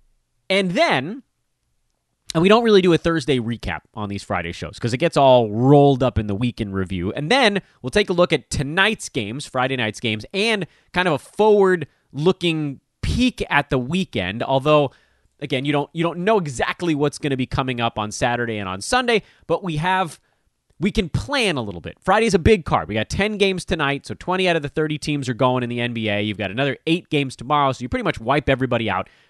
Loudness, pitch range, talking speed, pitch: -20 LUFS, 120-175 Hz, 220 wpm, 140 Hz